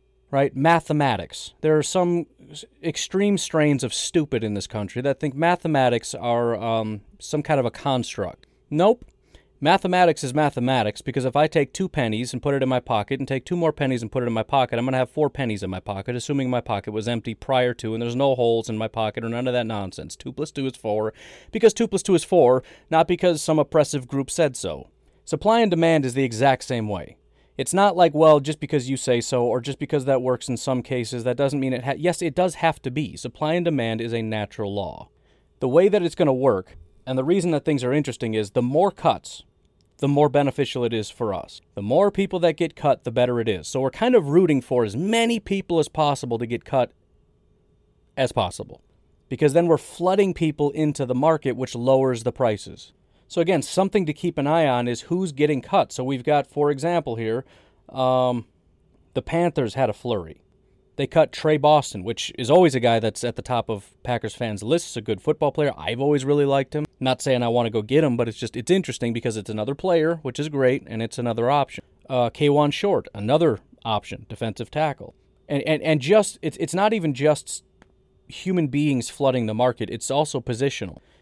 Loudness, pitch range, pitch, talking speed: -22 LUFS, 120-155 Hz, 135 Hz, 220 wpm